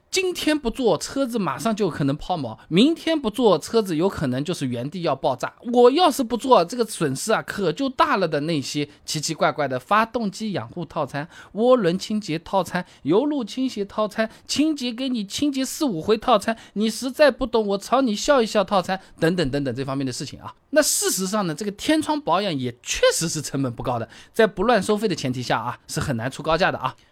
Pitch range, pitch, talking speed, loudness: 150-245 Hz, 205 Hz, 315 characters per minute, -22 LUFS